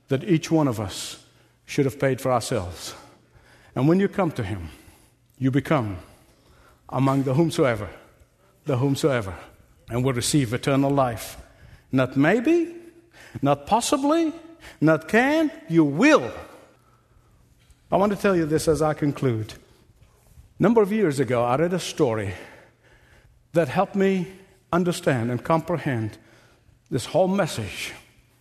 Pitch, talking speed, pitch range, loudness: 145 Hz, 135 wpm, 120-175 Hz, -23 LUFS